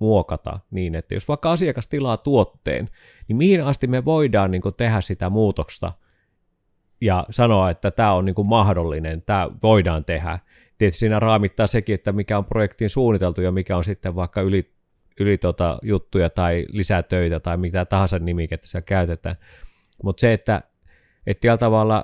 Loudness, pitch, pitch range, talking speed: -21 LUFS, 95 Hz, 90-110 Hz, 165 wpm